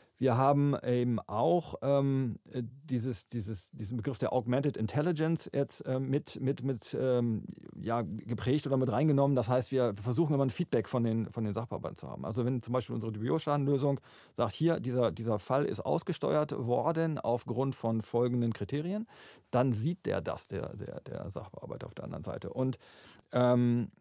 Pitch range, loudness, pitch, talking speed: 120-140 Hz, -32 LUFS, 130 Hz, 170 wpm